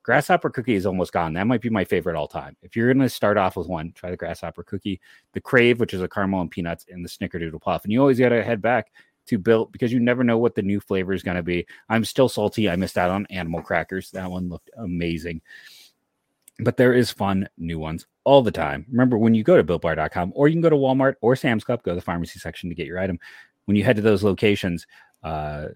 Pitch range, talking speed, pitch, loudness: 90-115 Hz, 250 wpm, 100 Hz, -22 LUFS